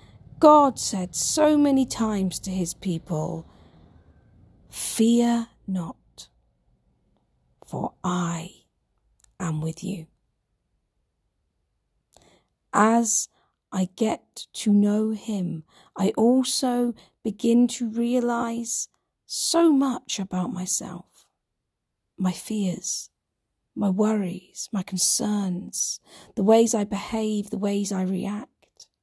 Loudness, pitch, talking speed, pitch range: -24 LUFS, 200 Hz, 90 wpm, 175-230 Hz